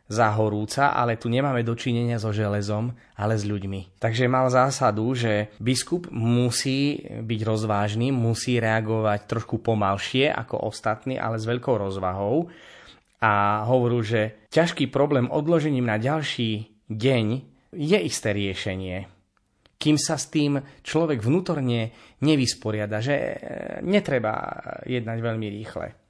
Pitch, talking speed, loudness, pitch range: 115 Hz, 120 wpm, -24 LUFS, 105-135 Hz